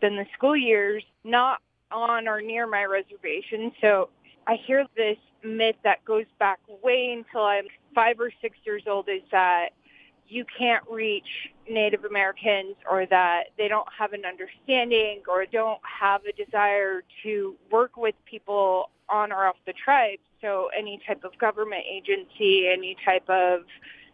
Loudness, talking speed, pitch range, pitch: -25 LUFS, 155 wpm, 195-230 Hz, 210 Hz